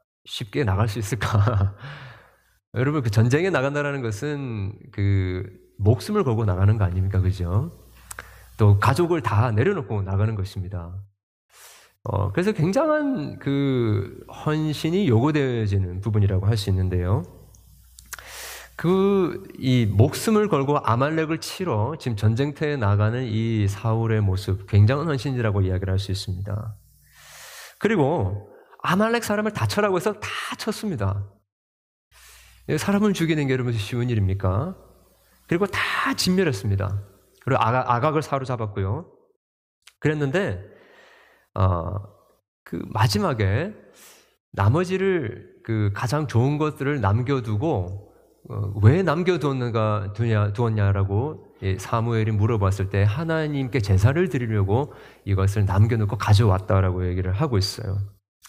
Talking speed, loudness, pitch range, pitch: 270 characters per minute, -23 LUFS, 100-145 Hz, 110 Hz